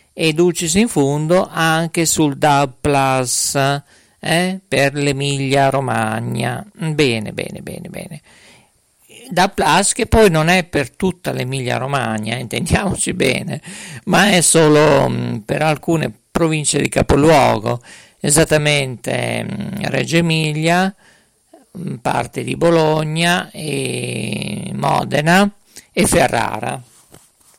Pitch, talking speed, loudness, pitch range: 155 Hz, 105 wpm, -16 LUFS, 135-170 Hz